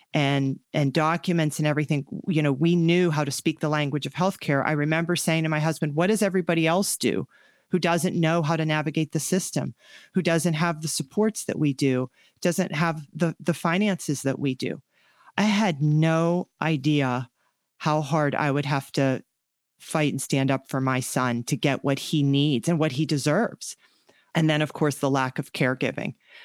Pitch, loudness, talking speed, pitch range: 155 Hz, -25 LUFS, 195 wpm, 140-170 Hz